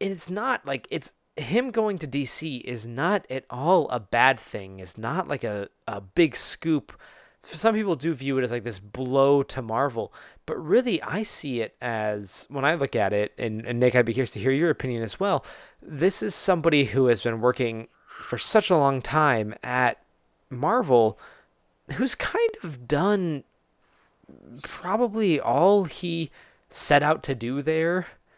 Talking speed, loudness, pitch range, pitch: 175 wpm, -25 LUFS, 120-170 Hz, 140 Hz